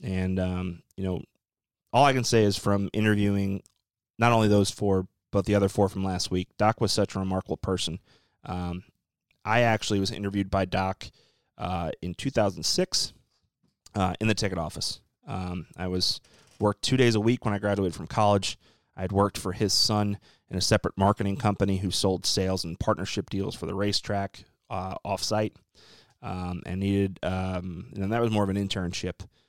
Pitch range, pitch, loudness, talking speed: 95-105 Hz, 100 Hz, -27 LUFS, 180 wpm